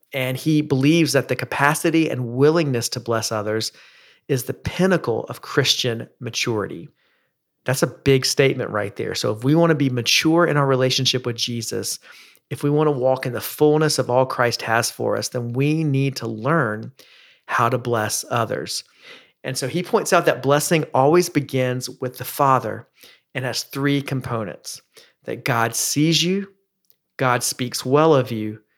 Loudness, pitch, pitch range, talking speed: -20 LUFS, 135 Hz, 120-150 Hz, 175 wpm